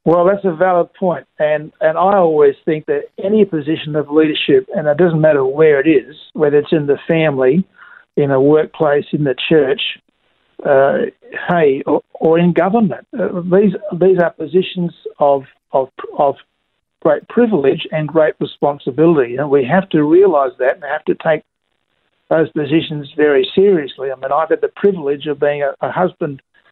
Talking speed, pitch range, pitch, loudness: 175 wpm, 150-195 Hz, 165 Hz, -15 LUFS